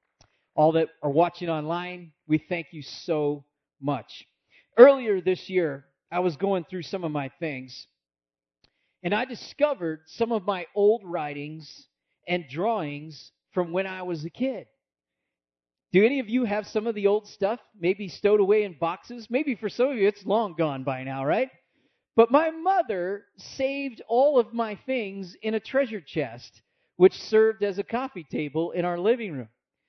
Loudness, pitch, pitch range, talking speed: -26 LUFS, 180 Hz, 155-220 Hz, 170 wpm